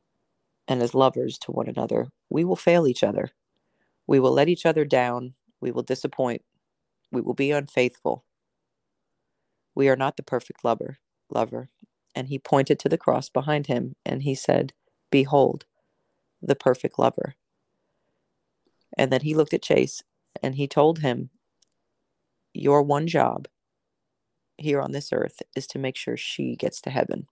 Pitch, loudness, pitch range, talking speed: 135 Hz, -24 LUFS, 130-145 Hz, 155 wpm